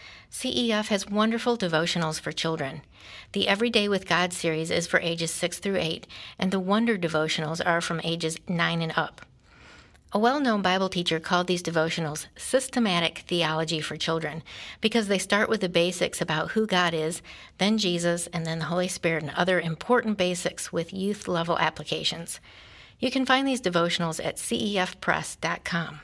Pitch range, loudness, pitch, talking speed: 165-205 Hz, -26 LUFS, 175 Hz, 165 wpm